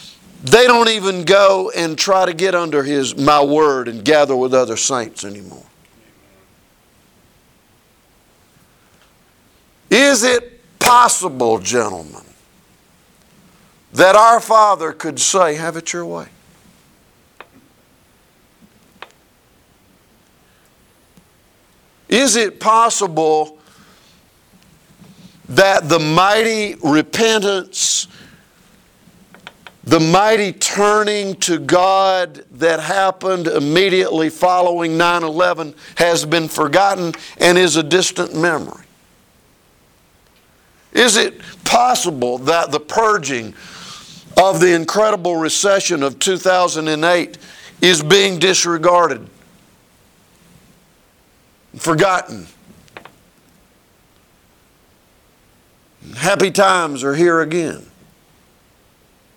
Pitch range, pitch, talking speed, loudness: 155-195 Hz, 175 Hz, 80 wpm, -14 LUFS